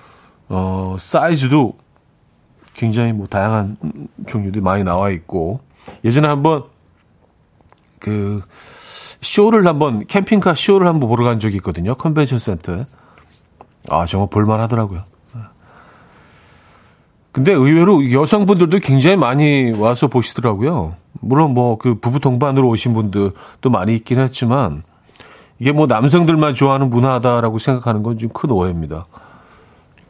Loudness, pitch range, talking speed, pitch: -15 LUFS, 100-145 Hz, 275 characters per minute, 120 Hz